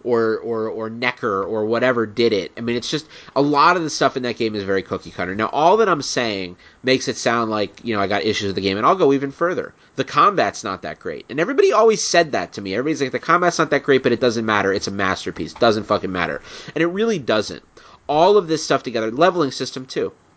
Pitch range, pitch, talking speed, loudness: 110-150 Hz, 120 Hz, 260 wpm, -19 LUFS